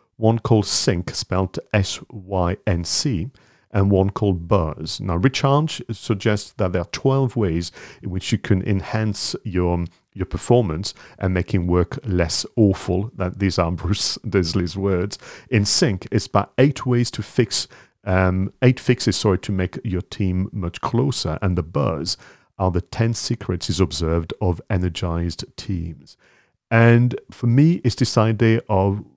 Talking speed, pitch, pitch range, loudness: 150 wpm, 100 Hz, 90-115 Hz, -21 LUFS